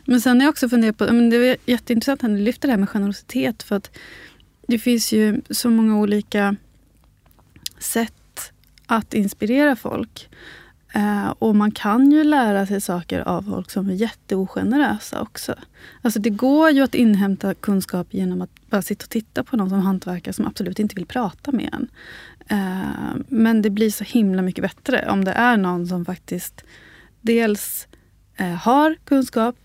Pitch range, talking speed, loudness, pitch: 200-245 Hz, 165 wpm, -20 LUFS, 220 Hz